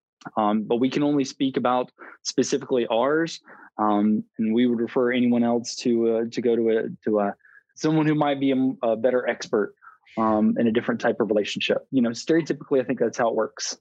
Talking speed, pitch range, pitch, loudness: 210 wpm, 115-130 Hz, 120 Hz, -23 LUFS